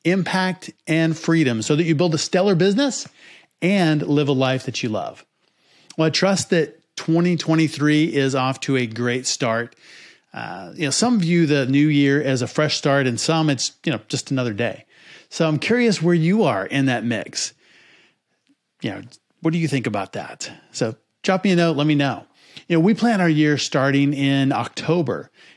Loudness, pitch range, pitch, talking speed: -20 LUFS, 135-175 Hz, 155 Hz, 190 wpm